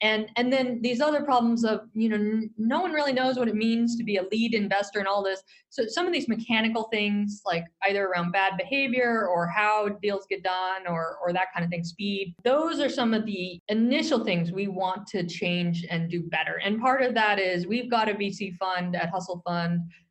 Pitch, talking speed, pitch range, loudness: 205 Hz, 225 wpm, 185-230 Hz, -26 LUFS